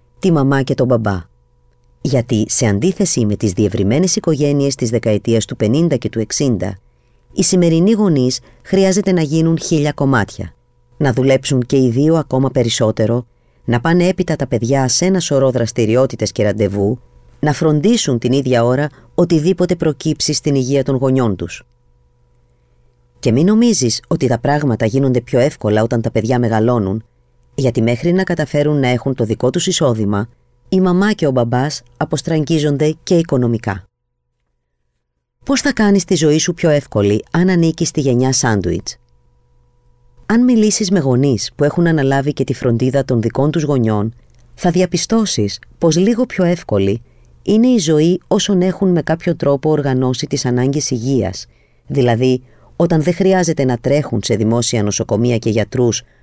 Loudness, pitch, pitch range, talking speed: -15 LUFS, 130 Hz, 110-160 Hz, 155 wpm